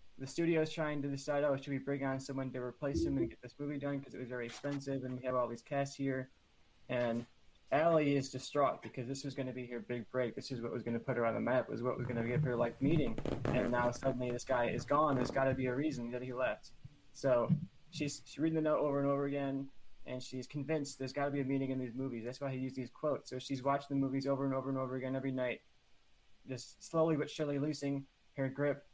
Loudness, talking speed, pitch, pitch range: -37 LUFS, 265 wpm, 135 Hz, 125-140 Hz